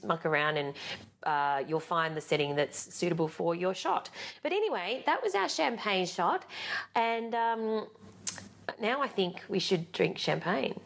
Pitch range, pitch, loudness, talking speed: 155-225 Hz, 180 Hz, -31 LUFS, 160 wpm